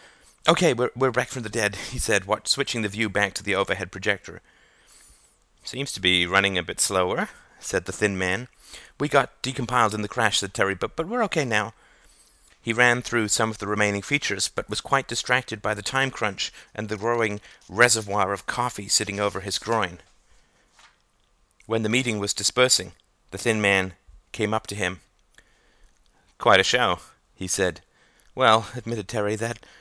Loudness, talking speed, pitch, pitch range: -24 LUFS, 175 wpm, 105 Hz, 100-120 Hz